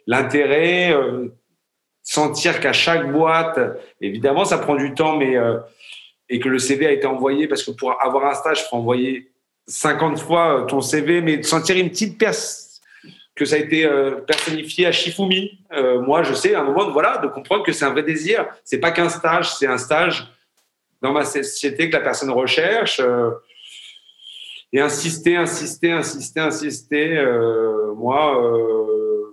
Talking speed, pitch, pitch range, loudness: 175 wpm, 155 Hz, 135-170 Hz, -19 LUFS